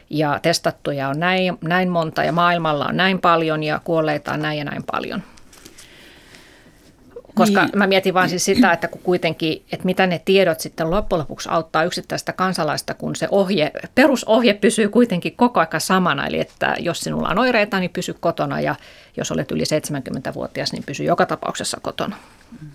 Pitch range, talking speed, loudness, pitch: 160-190 Hz, 170 wpm, -19 LUFS, 175 Hz